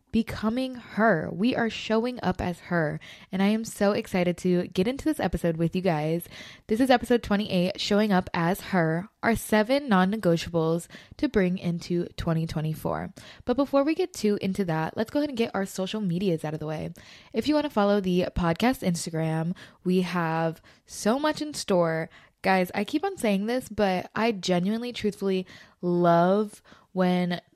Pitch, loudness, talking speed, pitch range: 190 Hz, -26 LUFS, 180 wpm, 175-220 Hz